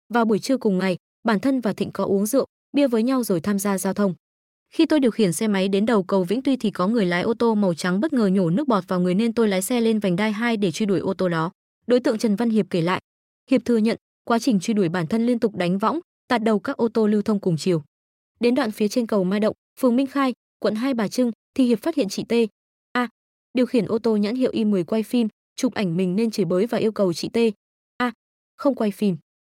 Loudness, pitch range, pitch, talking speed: -22 LUFS, 195-240 Hz, 220 Hz, 275 wpm